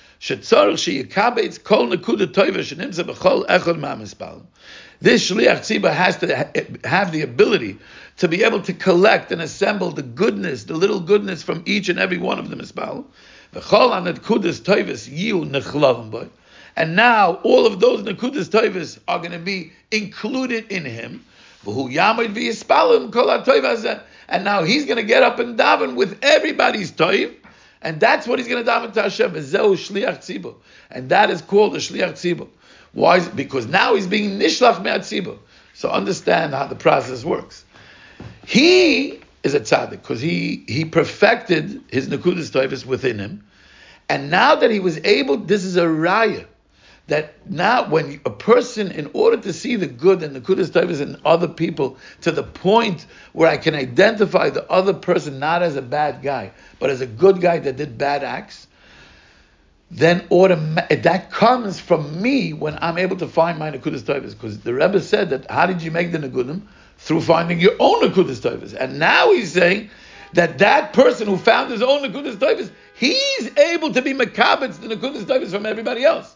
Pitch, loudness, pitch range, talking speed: 190 Hz, -18 LUFS, 165-235 Hz, 155 wpm